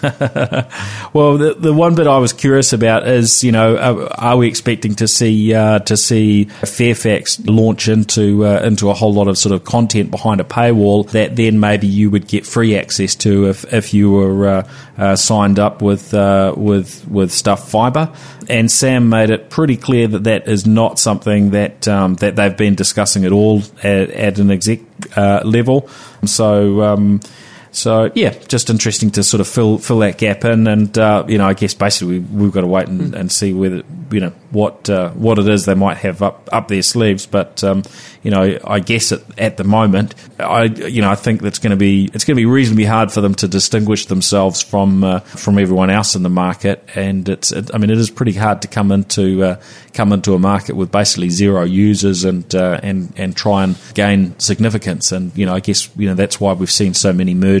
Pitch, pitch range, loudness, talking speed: 105 Hz, 100-110 Hz, -13 LUFS, 220 wpm